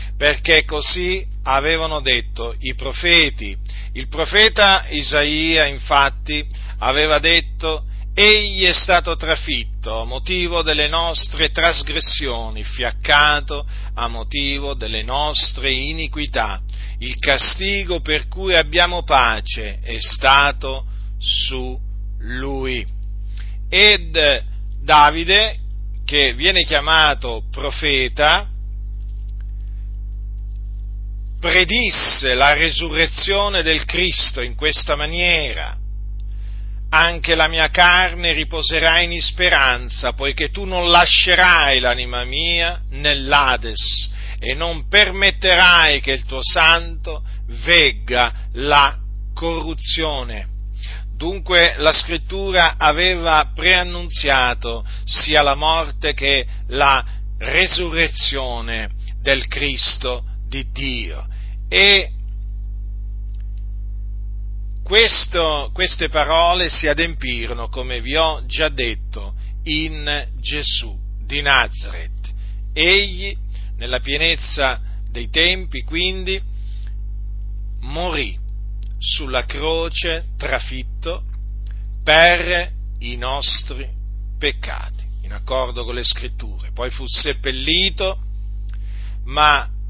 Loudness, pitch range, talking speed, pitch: -15 LUFS, 100-160 Hz, 85 wpm, 130 Hz